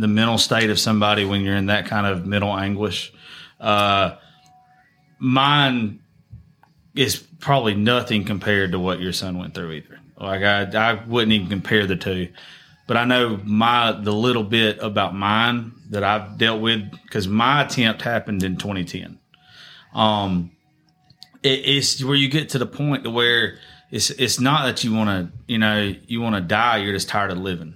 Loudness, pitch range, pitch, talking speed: -20 LUFS, 100-120 Hz, 110 Hz, 175 wpm